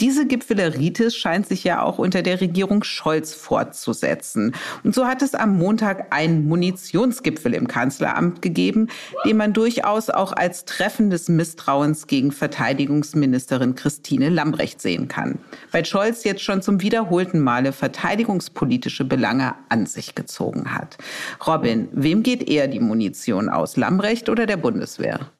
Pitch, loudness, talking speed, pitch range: 190 Hz, -21 LUFS, 140 wpm, 155-225 Hz